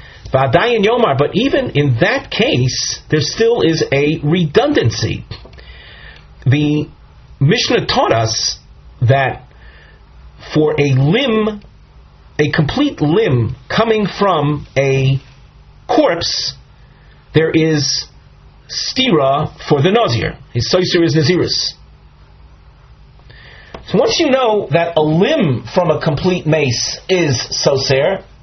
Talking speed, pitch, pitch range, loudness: 100 wpm, 145 Hz, 125-165 Hz, -14 LUFS